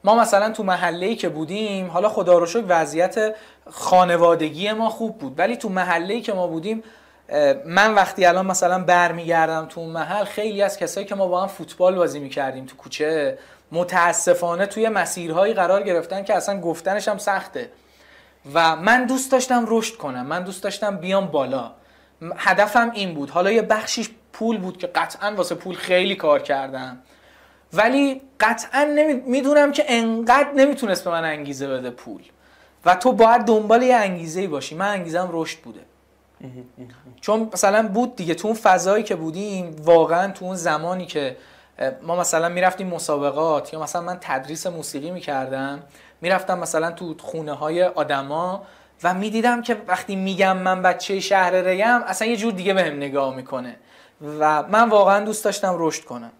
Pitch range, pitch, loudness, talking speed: 165-215 Hz, 185 Hz, -20 LUFS, 165 wpm